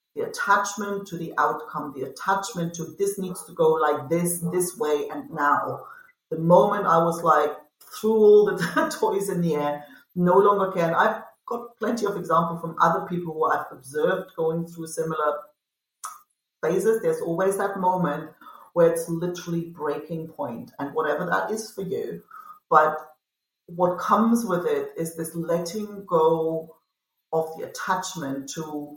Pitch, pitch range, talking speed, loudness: 170 Hz, 160-205 Hz, 160 wpm, -24 LUFS